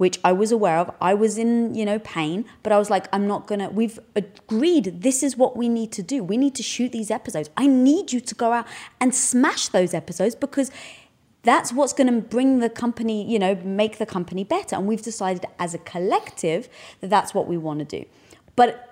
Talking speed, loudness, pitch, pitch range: 230 wpm, -22 LUFS, 225 Hz, 195-250 Hz